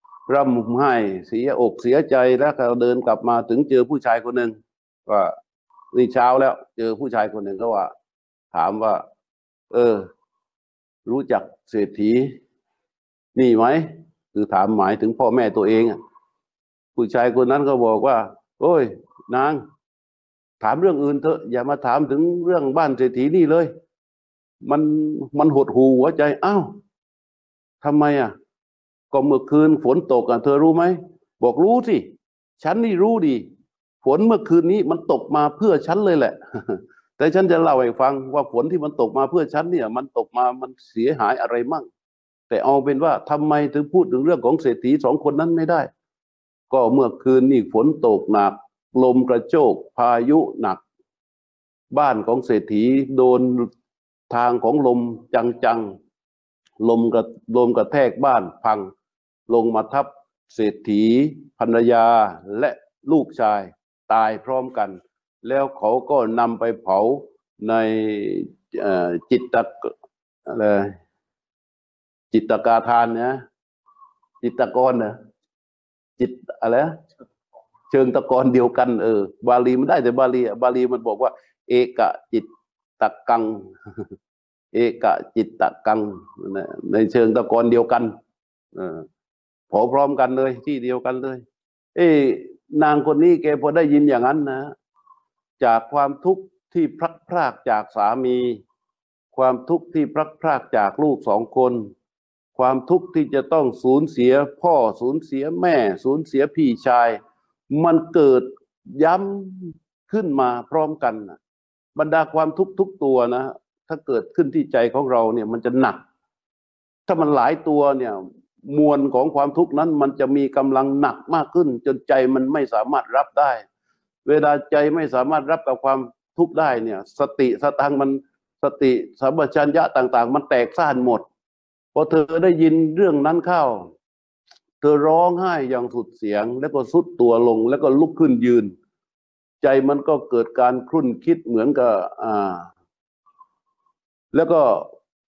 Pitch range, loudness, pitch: 120-160 Hz, -19 LUFS, 135 Hz